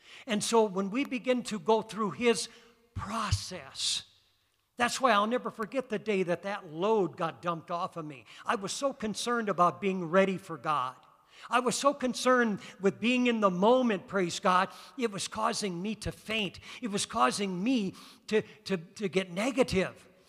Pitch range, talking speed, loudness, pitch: 185-235 Hz, 175 wpm, -30 LUFS, 210 Hz